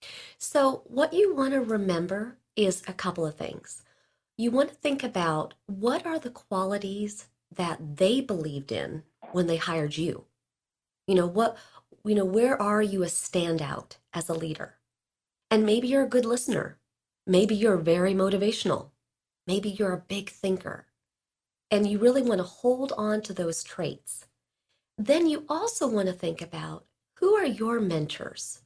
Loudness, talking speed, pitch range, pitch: -27 LUFS, 160 wpm, 175-245 Hz, 205 Hz